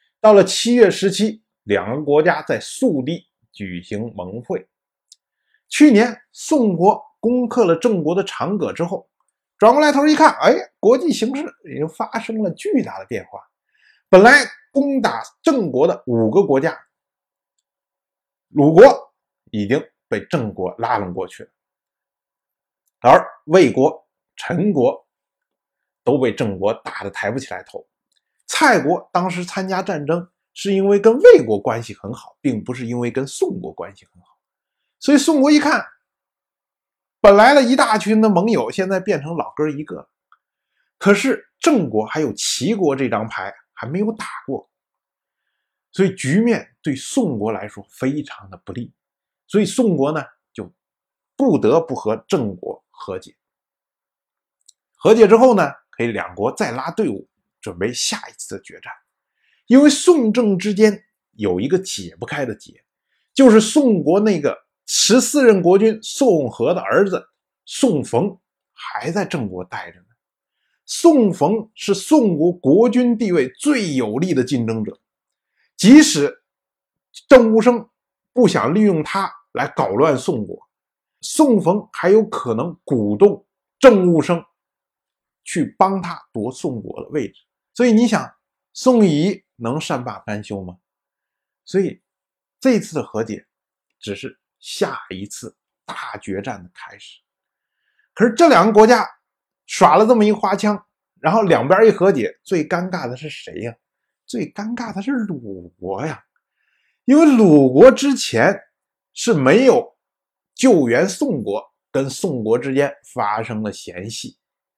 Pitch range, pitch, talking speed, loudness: 155-245 Hz, 205 Hz, 205 characters per minute, -16 LUFS